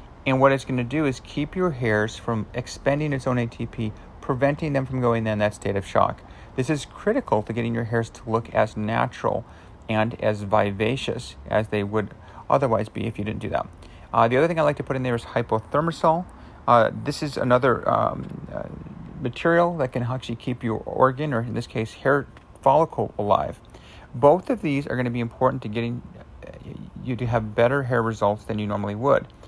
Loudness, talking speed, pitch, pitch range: -24 LUFS, 205 wpm, 120 Hz, 110-135 Hz